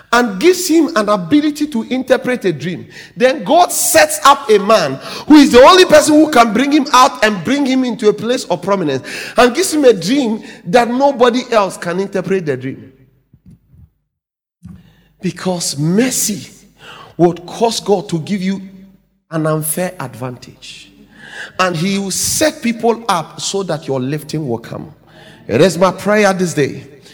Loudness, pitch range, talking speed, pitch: -13 LUFS, 170-250 Hz, 165 wpm, 205 Hz